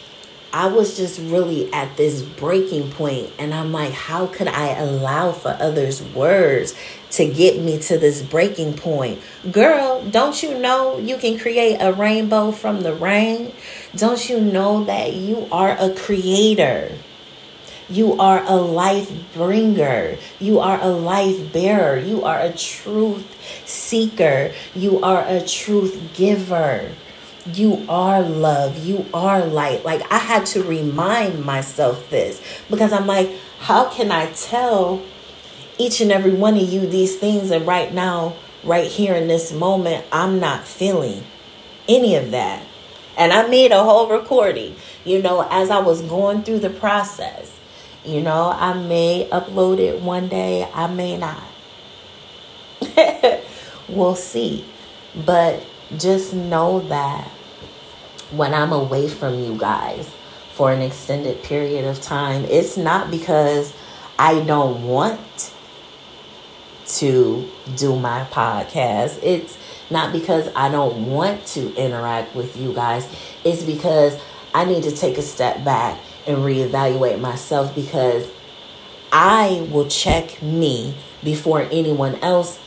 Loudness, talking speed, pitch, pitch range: -18 LUFS, 140 wpm, 175 Hz, 150-200 Hz